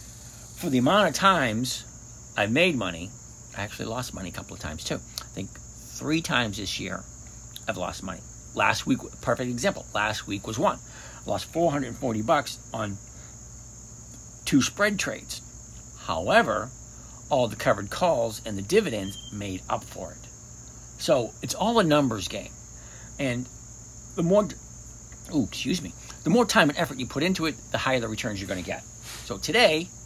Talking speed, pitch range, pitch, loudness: 170 wpm, 100-145 Hz, 120 Hz, -26 LUFS